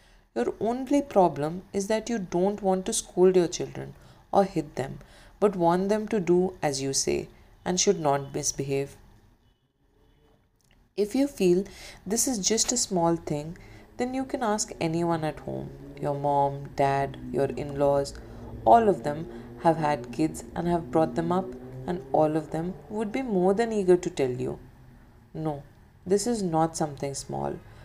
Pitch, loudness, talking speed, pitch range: 165 Hz, -27 LUFS, 170 wpm, 135-195 Hz